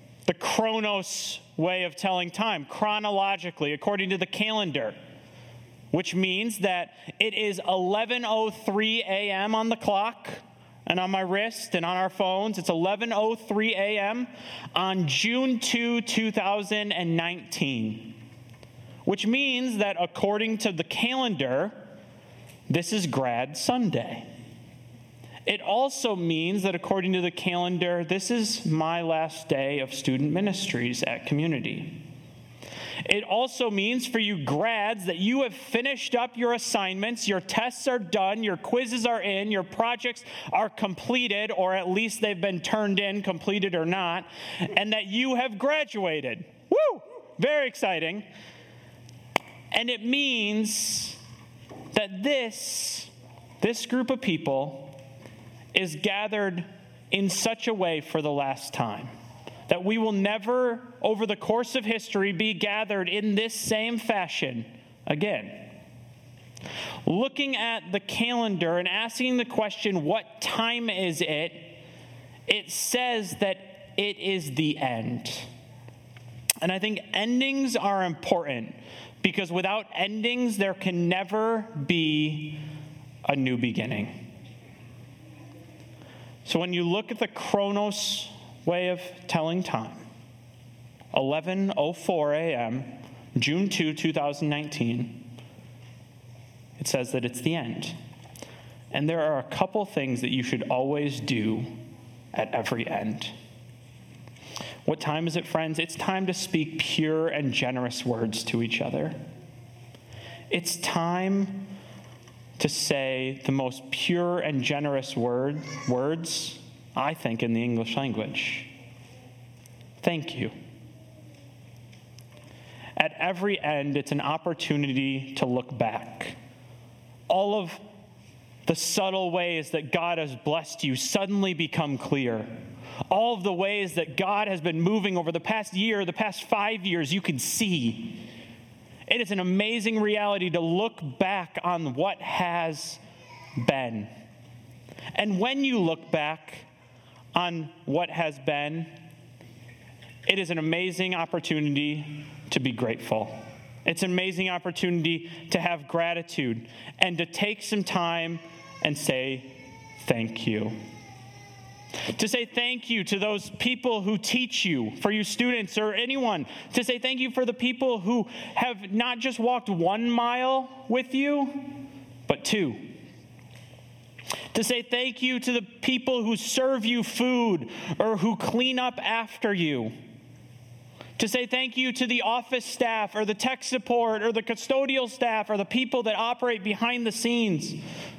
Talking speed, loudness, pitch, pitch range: 135 wpm, -27 LUFS, 180 Hz, 130-215 Hz